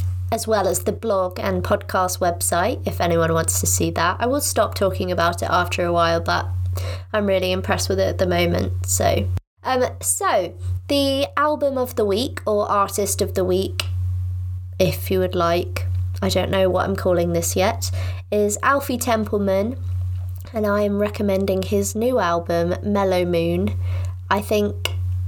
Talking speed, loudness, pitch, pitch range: 165 wpm, -21 LUFS, 90 Hz, 90-105 Hz